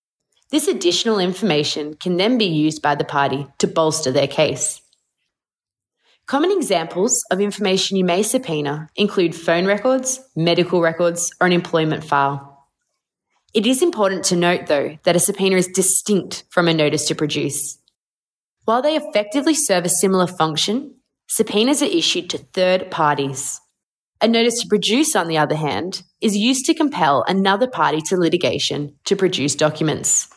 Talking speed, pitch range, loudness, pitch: 155 wpm, 155-220 Hz, -18 LUFS, 180 Hz